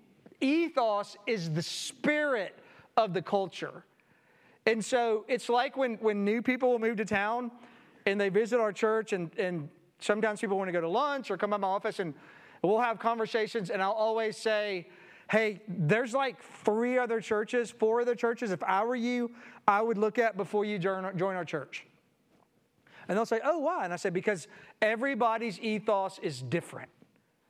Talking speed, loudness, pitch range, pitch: 180 wpm, -30 LUFS, 195-235 Hz, 215 Hz